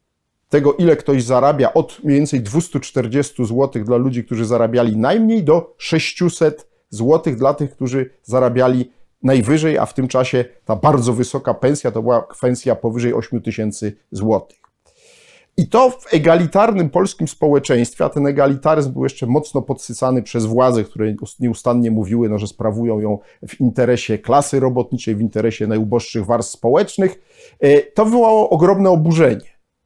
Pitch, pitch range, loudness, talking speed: 130 Hz, 120-155 Hz, -16 LUFS, 145 wpm